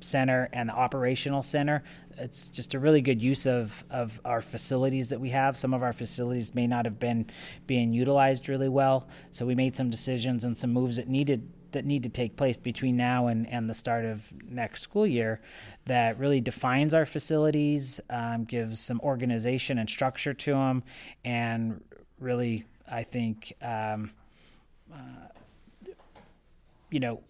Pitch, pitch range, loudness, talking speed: 125 Hz, 120-135 Hz, -28 LUFS, 165 wpm